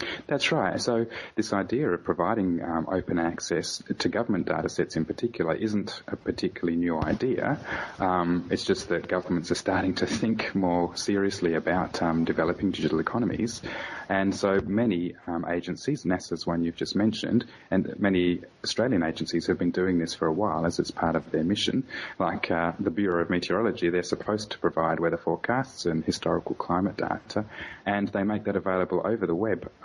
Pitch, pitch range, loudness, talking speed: 90 Hz, 85-100 Hz, -27 LUFS, 175 wpm